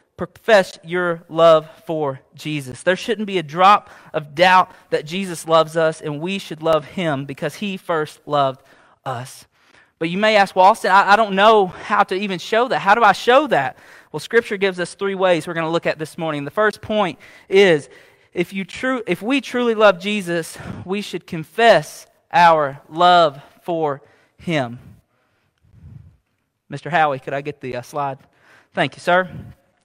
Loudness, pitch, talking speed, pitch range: -18 LUFS, 170 Hz, 180 wpm, 150-200 Hz